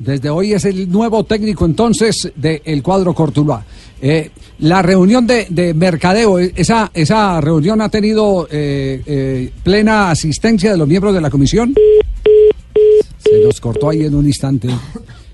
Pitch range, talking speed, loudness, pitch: 150-215 Hz, 155 wpm, -12 LUFS, 180 Hz